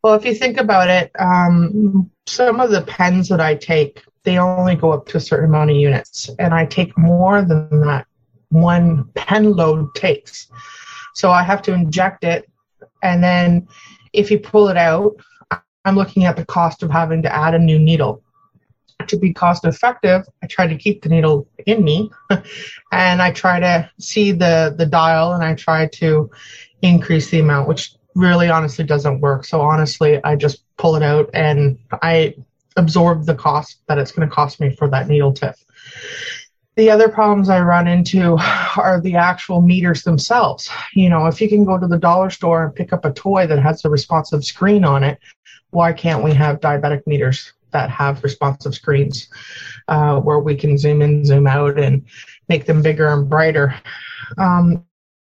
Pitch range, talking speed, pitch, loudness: 150-180 Hz, 185 wpm, 165 Hz, -15 LUFS